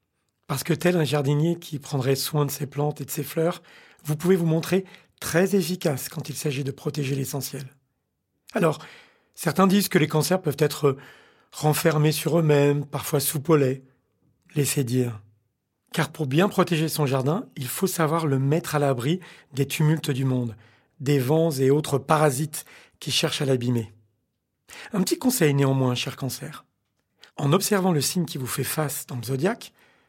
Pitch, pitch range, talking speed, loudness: 150 Hz, 135-165 Hz, 170 wpm, -24 LUFS